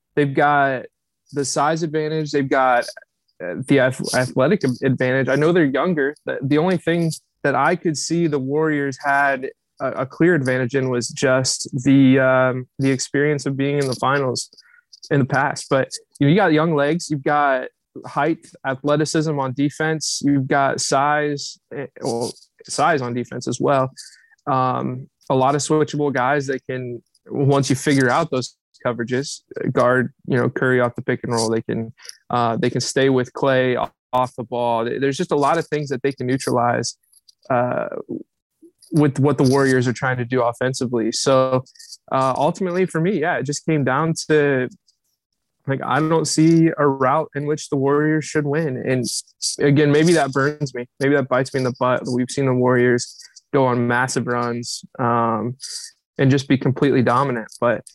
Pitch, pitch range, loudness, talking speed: 140 Hz, 125-150 Hz, -19 LUFS, 175 wpm